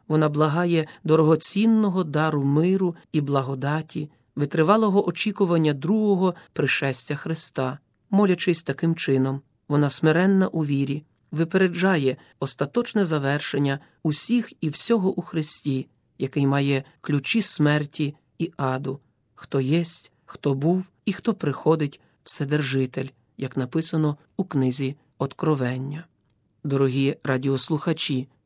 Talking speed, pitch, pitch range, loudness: 100 wpm, 150 Hz, 135-170 Hz, -24 LUFS